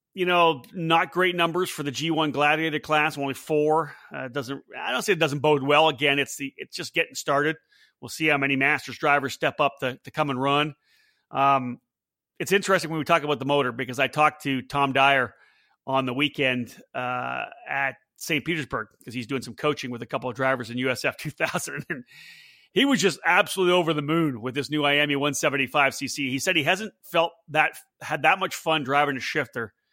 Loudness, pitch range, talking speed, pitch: -24 LUFS, 135-160 Hz, 205 wpm, 145 Hz